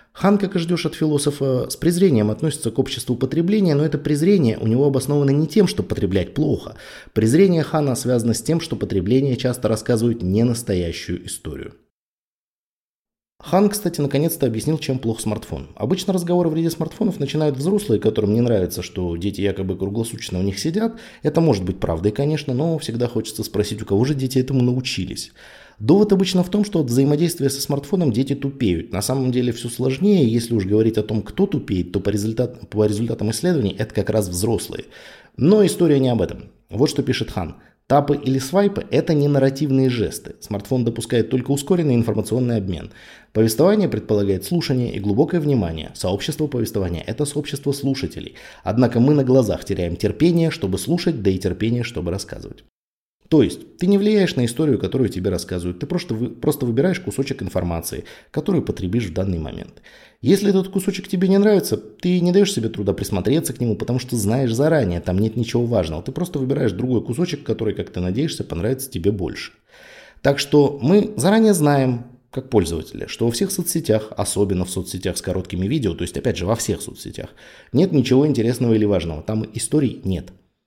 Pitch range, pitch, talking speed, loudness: 105-150 Hz, 125 Hz, 180 wpm, -20 LUFS